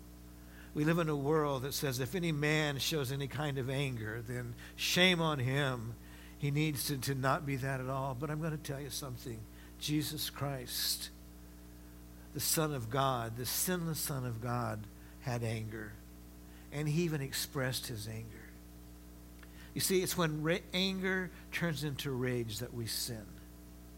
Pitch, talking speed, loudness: 130 Hz, 165 wpm, -35 LUFS